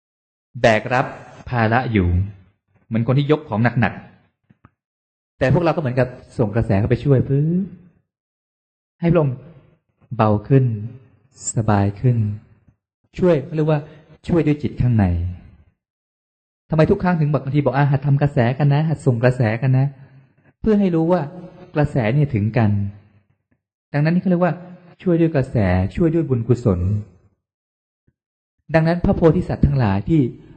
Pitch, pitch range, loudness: 130 Hz, 105-155 Hz, -19 LUFS